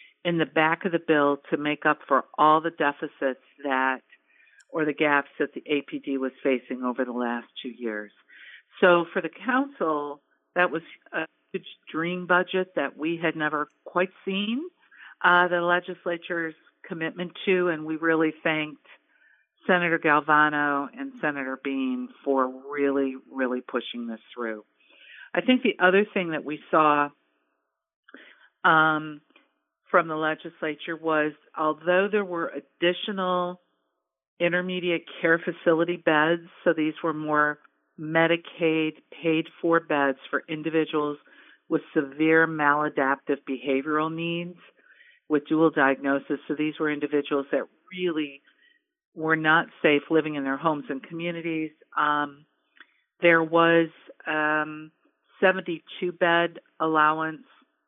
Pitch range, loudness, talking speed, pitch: 145-170 Hz, -25 LUFS, 130 wpm, 155 Hz